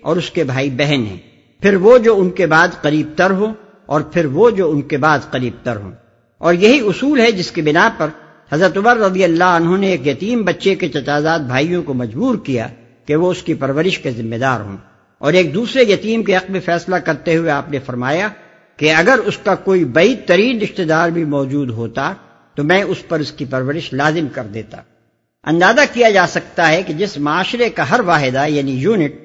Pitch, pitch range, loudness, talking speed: 165 Hz, 140-185 Hz, -15 LUFS, 215 wpm